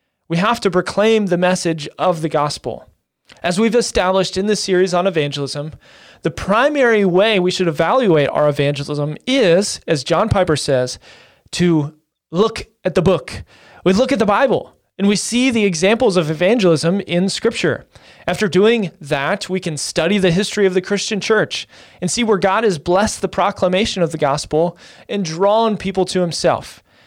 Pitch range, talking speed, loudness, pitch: 165-205 Hz, 170 wpm, -17 LUFS, 185 Hz